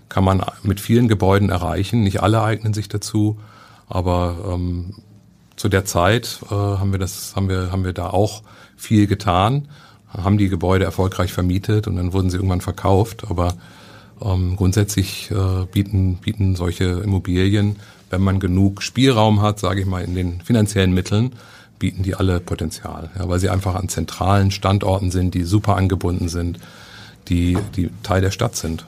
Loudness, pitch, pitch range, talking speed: -19 LUFS, 95 Hz, 90-105 Hz, 170 wpm